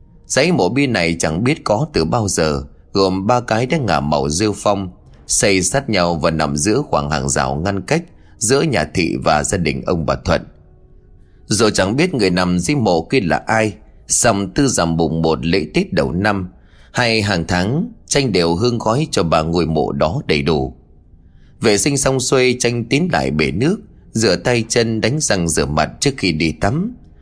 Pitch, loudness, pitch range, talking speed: 95 Hz, -16 LUFS, 80-120 Hz, 200 wpm